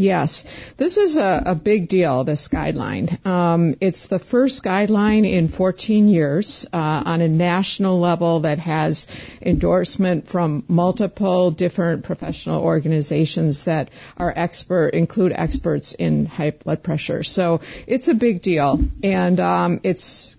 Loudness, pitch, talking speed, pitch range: -19 LUFS, 175 Hz, 140 wpm, 160-190 Hz